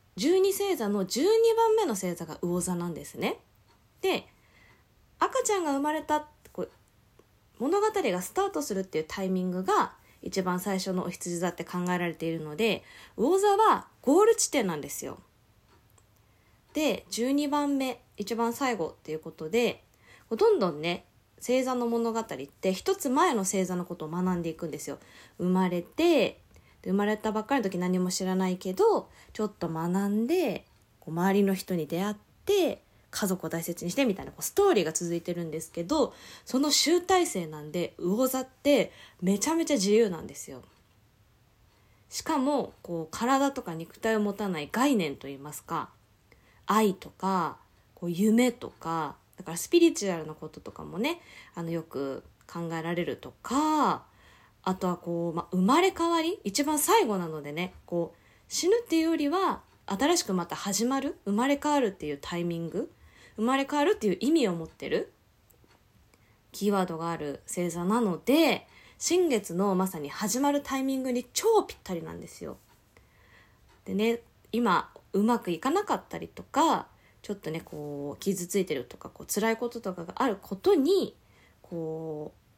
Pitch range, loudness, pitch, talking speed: 170-275 Hz, -28 LUFS, 195 Hz, 320 characters per minute